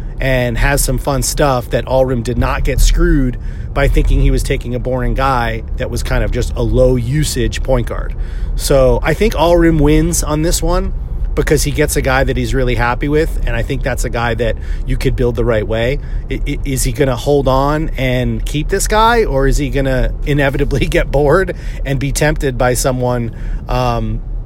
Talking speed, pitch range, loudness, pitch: 205 wpm, 120-145 Hz, -15 LUFS, 130 Hz